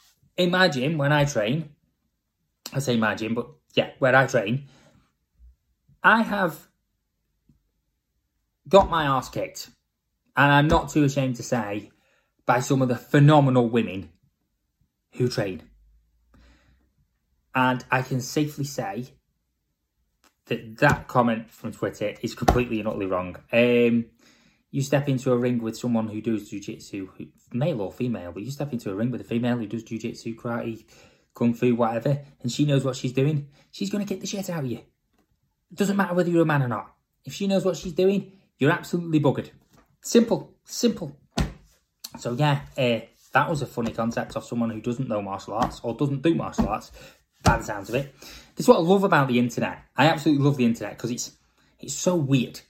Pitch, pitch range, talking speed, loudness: 125 Hz, 110-145 Hz, 180 wpm, -24 LUFS